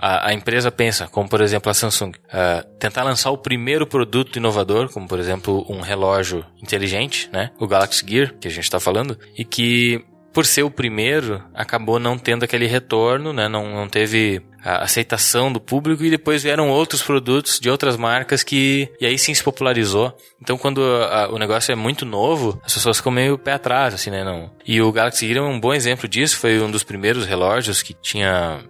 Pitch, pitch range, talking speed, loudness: 120 Hz, 105-135 Hz, 205 wpm, -18 LUFS